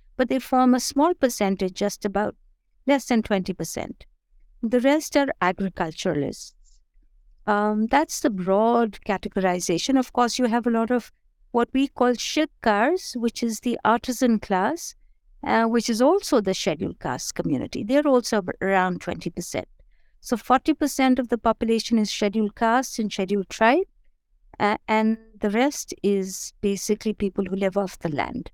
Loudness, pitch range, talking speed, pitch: -23 LUFS, 200-255 Hz, 150 wpm, 225 Hz